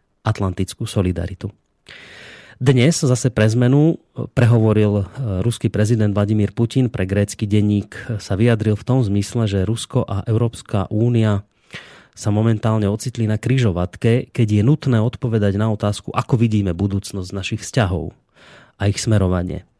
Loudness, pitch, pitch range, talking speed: -19 LUFS, 110 Hz, 100-120 Hz, 130 wpm